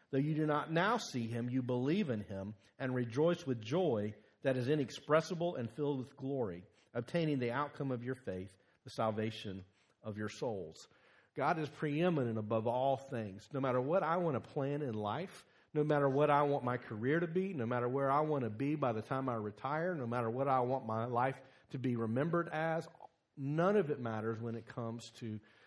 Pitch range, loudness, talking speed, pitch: 115-150 Hz, -37 LUFS, 205 wpm, 130 Hz